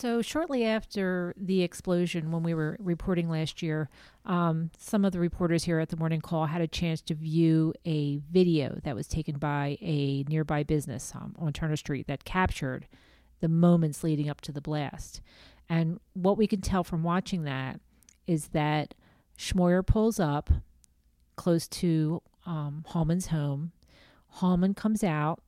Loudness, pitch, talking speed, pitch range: -29 LUFS, 165 Hz, 160 wpm, 150-175 Hz